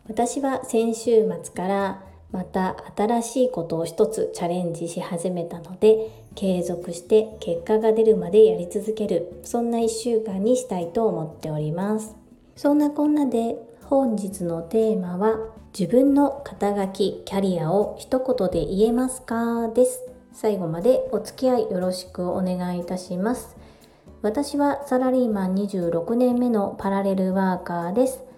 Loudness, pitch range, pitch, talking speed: -23 LUFS, 180-240 Hz, 215 Hz, 295 characters per minute